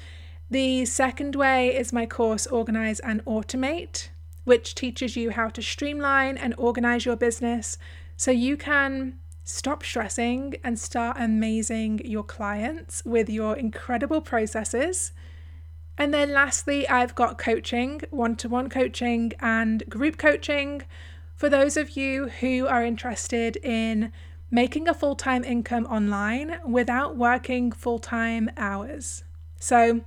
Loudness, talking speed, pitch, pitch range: -25 LUFS, 125 wpm, 235 Hz, 220-260 Hz